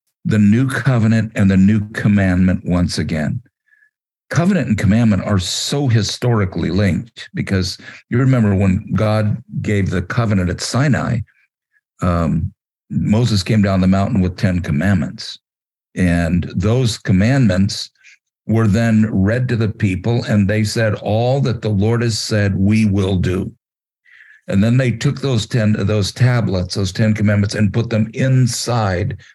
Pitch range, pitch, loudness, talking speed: 95-115 Hz, 105 Hz, -16 LUFS, 145 wpm